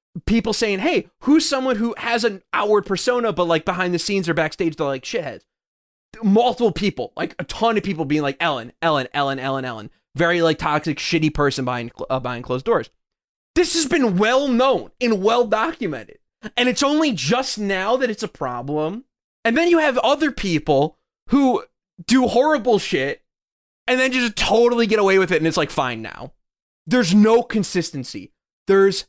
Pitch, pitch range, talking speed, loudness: 205 Hz, 155-240 Hz, 180 wpm, -19 LUFS